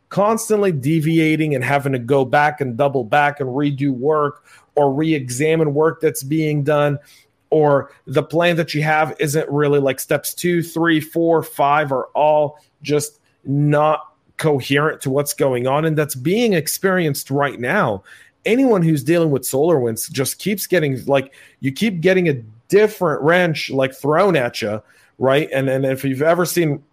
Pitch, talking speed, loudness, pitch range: 150 Hz, 170 wpm, -18 LUFS, 140-160 Hz